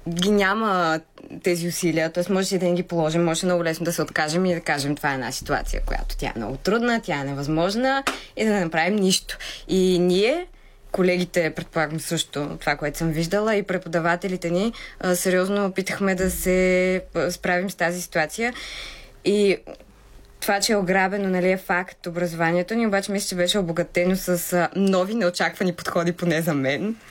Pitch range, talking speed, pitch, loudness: 165-190 Hz, 175 wpm, 180 Hz, -23 LUFS